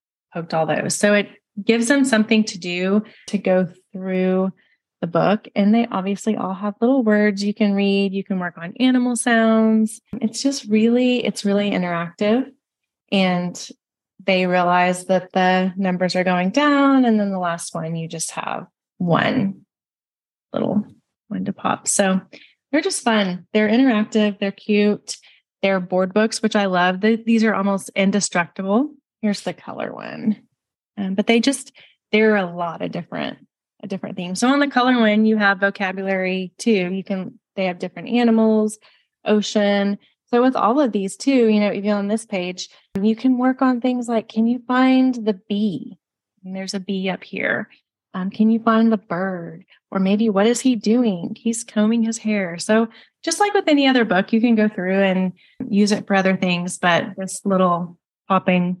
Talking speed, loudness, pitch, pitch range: 180 wpm, -19 LUFS, 205 Hz, 190-225 Hz